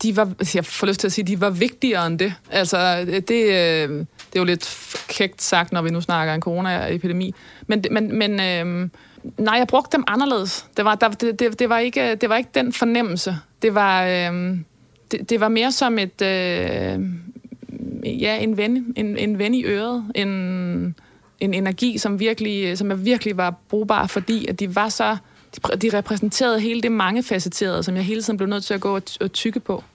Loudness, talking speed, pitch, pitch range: -21 LUFS, 190 wpm, 205 Hz, 185-230 Hz